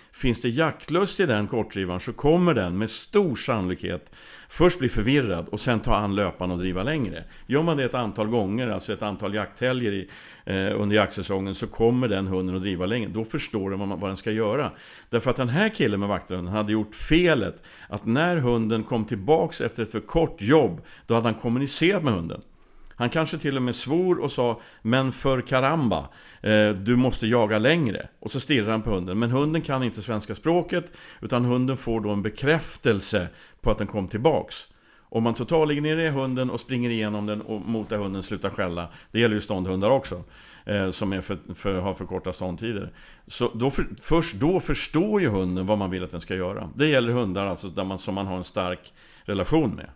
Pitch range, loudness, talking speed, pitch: 100-135 Hz, -25 LUFS, 205 wpm, 110 Hz